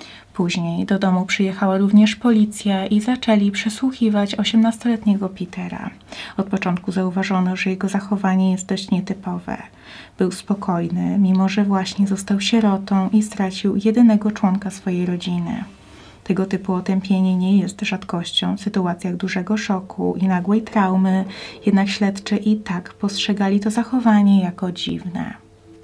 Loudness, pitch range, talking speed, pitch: -19 LUFS, 185-210 Hz, 130 wpm, 195 Hz